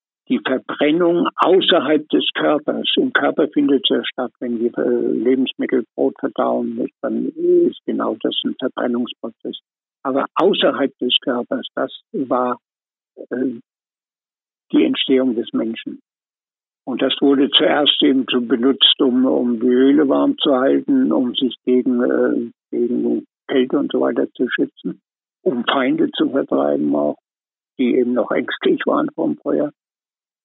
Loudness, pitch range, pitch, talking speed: -18 LUFS, 120-175 Hz, 130 Hz, 135 wpm